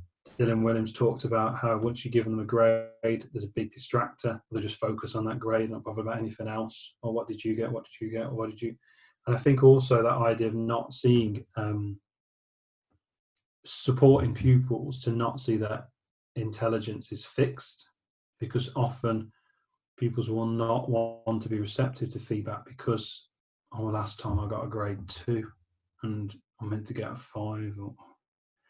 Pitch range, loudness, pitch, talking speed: 110-120 Hz, -29 LUFS, 115 Hz, 180 wpm